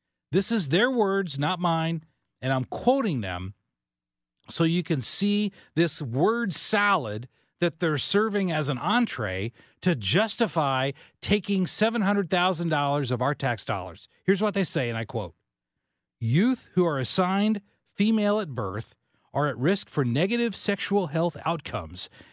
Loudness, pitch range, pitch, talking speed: -26 LUFS, 130-200 Hz, 165 Hz, 140 wpm